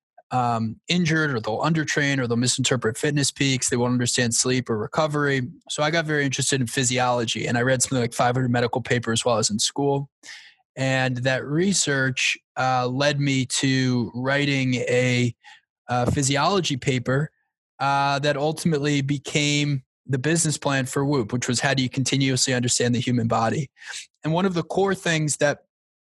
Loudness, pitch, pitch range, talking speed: -22 LUFS, 135 Hz, 125-145 Hz, 170 wpm